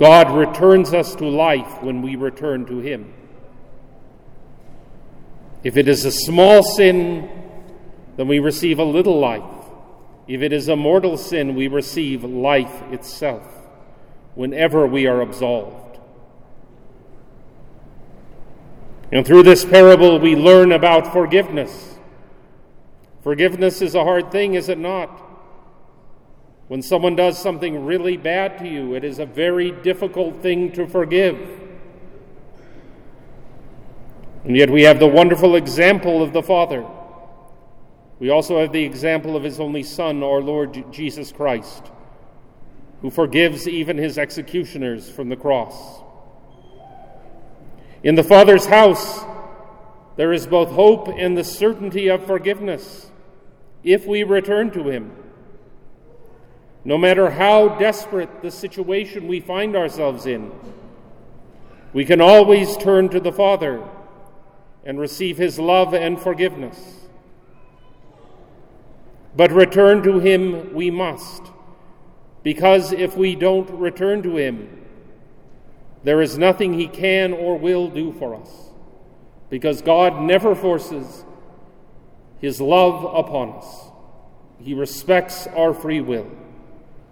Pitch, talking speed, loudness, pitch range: 175 Hz, 120 wpm, -16 LUFS, 145-185 Hz